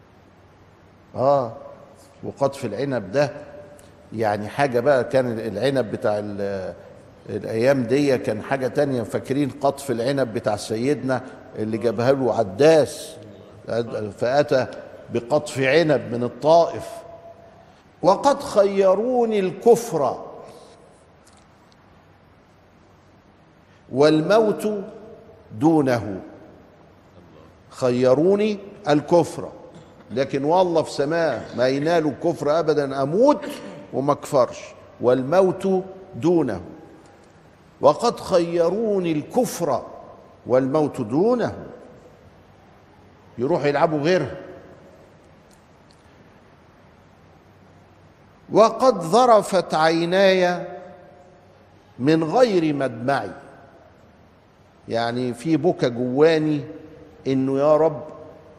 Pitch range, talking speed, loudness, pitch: 115-170 Hz, 70 wpm, -21 LUFS, 145 Hz